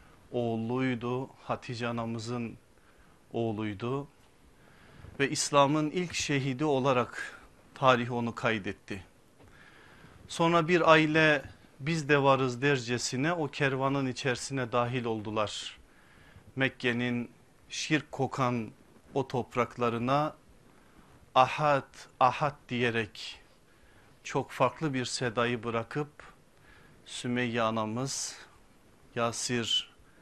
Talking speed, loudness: 80 wpm, -30 LUFS